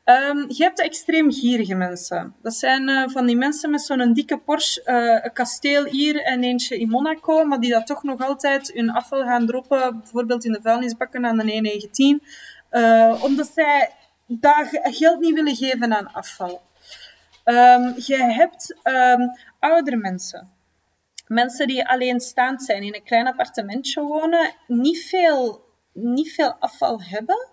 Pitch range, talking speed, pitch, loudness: 235-295 Hz, 160 wpm, 255 Hz, -19 LUFS